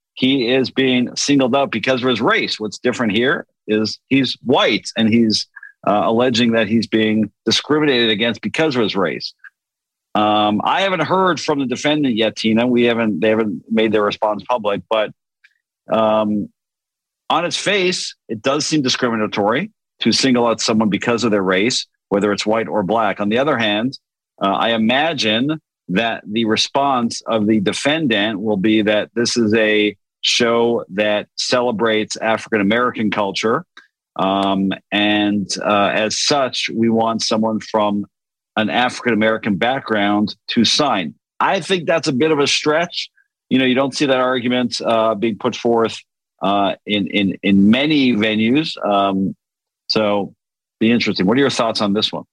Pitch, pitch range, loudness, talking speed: 115 Hz, 105-125 Hz, -17 LUFS, 165 wpm